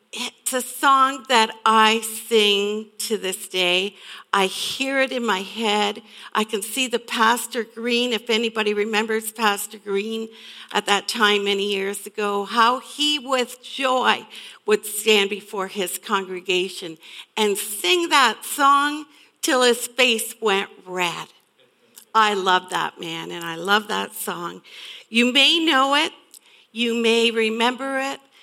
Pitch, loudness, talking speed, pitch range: 220 Hz, -20 LUFS, 140 wpm, 205-250 Hz